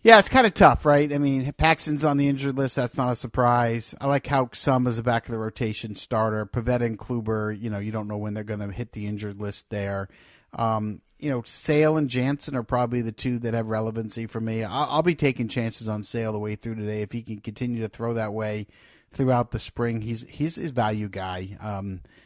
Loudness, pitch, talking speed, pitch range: -25 LUFS, 115 Hz, 235 wpm, 105-130 Hz